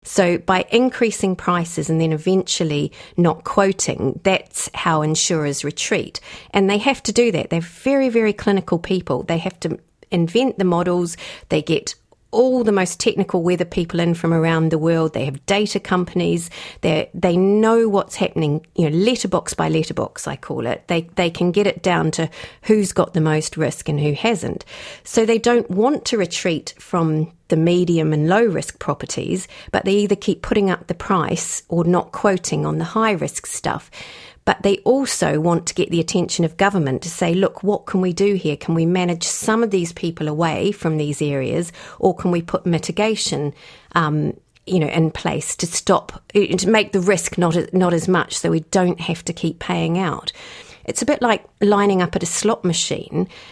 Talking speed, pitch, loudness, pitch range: 190 wpm, 180 Hz, -19 LUFS, 165-200 Hz